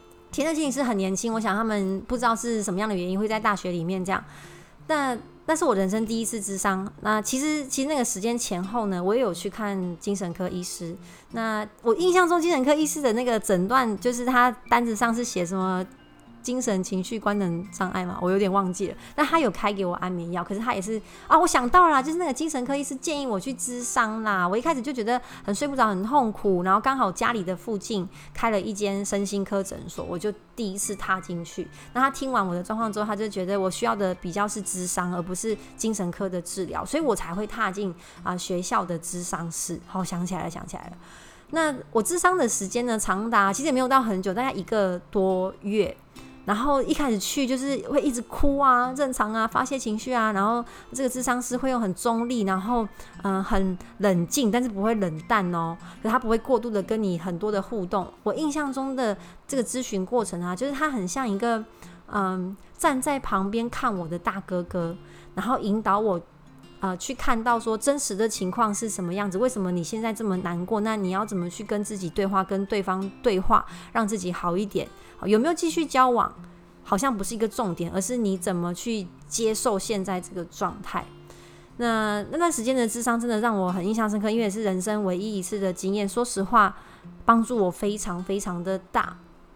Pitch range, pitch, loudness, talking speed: 190-240 Hz, 210 Hz, -26 LUFS, 315 characters per minute